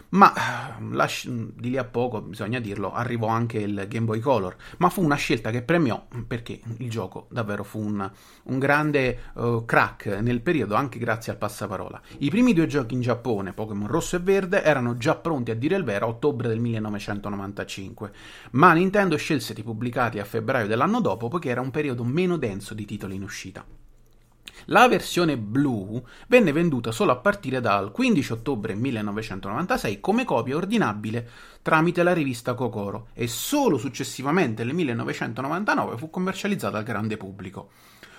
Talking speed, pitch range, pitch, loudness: 165 wpm, 105-150 Hz, 120 Hz, -24 LUFS